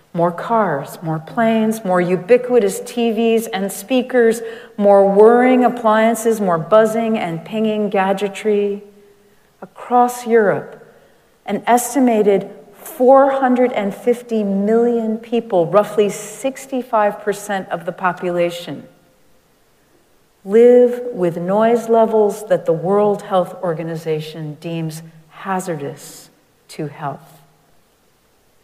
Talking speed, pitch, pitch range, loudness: 90 wpm, 210 Hz, 185-230 Hz, -16 LUFS